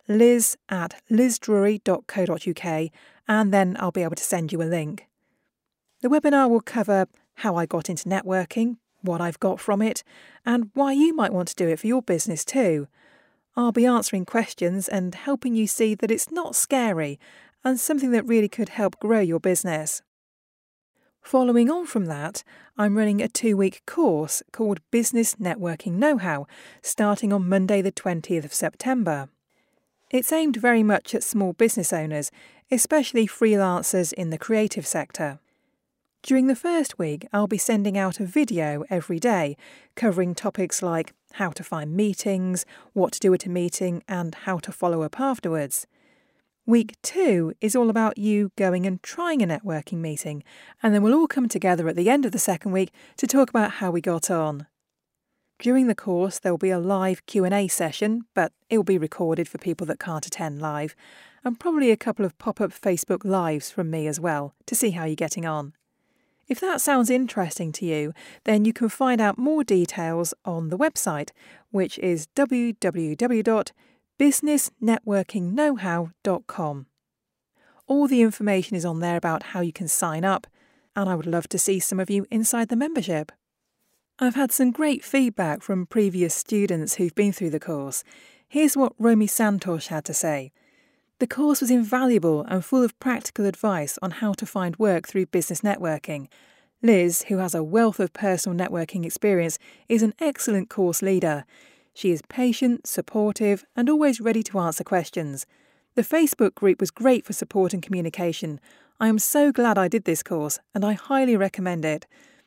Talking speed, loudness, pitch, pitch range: 170 wpm, -23 LUFS, 200 Hz, 175-245 Hz